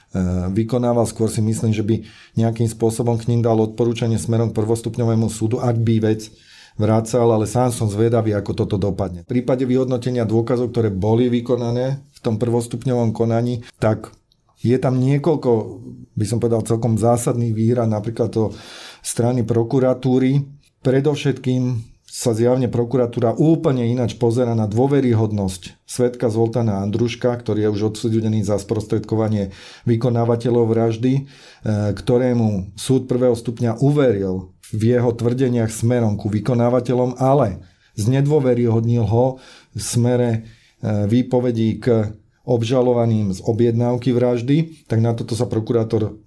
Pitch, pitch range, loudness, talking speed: 115 Hz, 110-125 Hz, -19 LUFS, 125 wpm